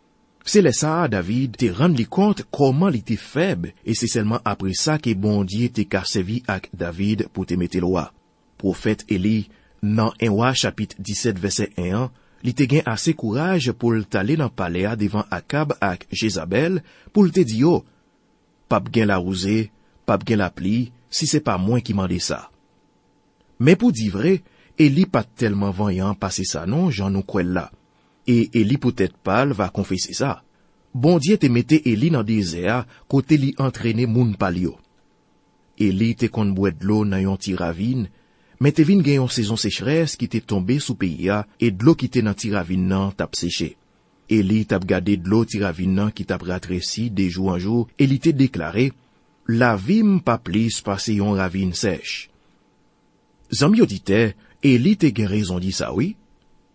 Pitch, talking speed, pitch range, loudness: 110 Hz, 175 wpm, 95-125 Hz, -21 LUFS